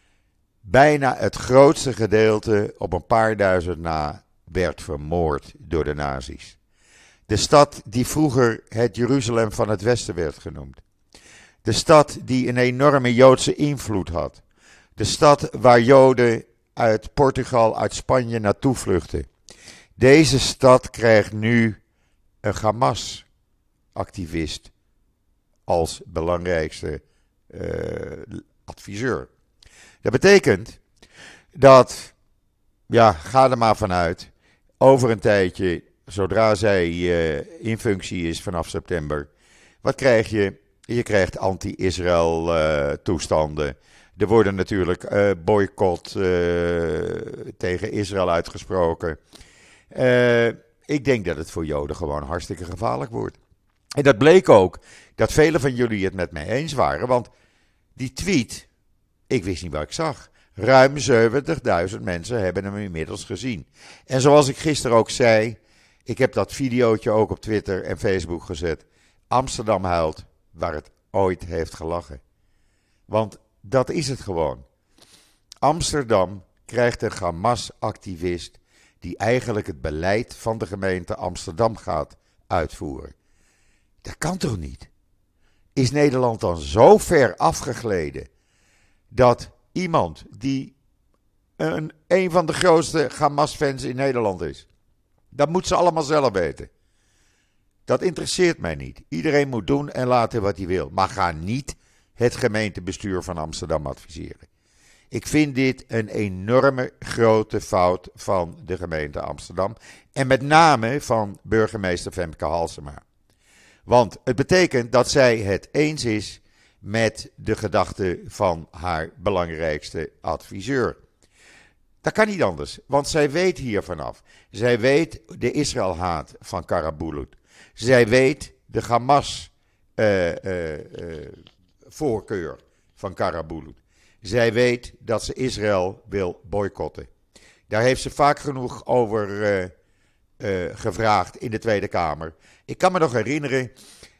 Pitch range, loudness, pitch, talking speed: 90-125 Hz, -21 LUFS, 105 Hz, 125 wpm